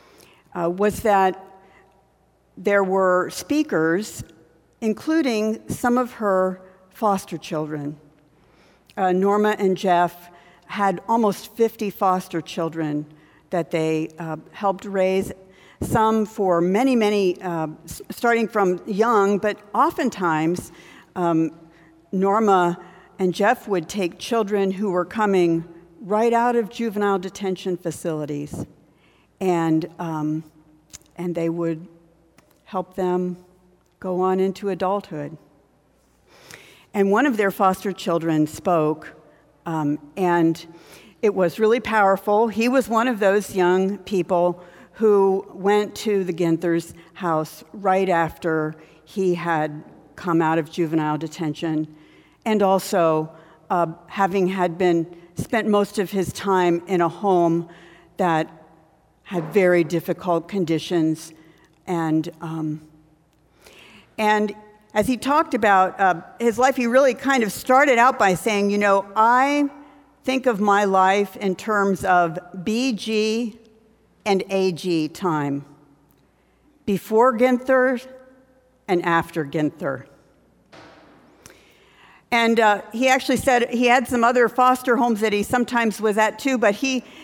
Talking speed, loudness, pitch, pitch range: 120 wpm, -21 LUFS, 190 Hz, 170-215 Hz